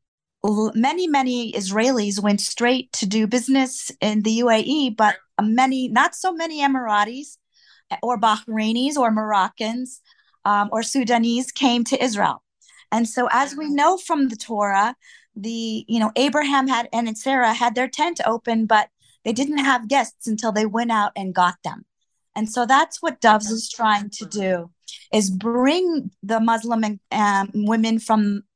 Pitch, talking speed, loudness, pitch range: 230 Hz, 160 wpm, -20 LUFS, 215-260 Hz